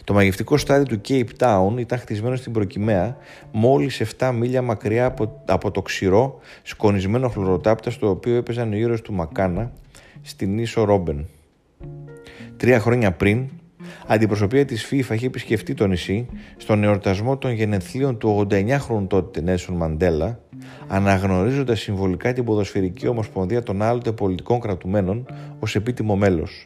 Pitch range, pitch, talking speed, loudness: 95-125 Hz, 110 Hz, 135 wpm, -21 LUFS